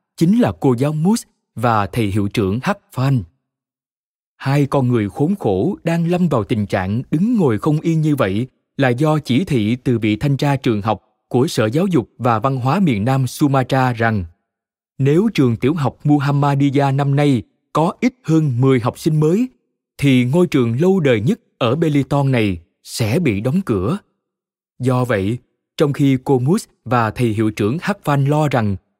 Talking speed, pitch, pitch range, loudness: 185 wpm, 135 Hz, 120-155 Hz, -17 LUFS